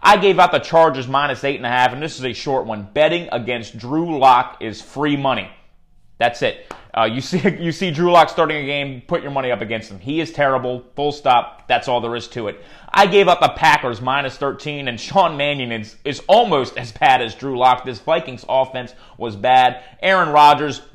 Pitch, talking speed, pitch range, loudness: 135 Hz, 220 wpm, 125-155 Hz, -17 LUFS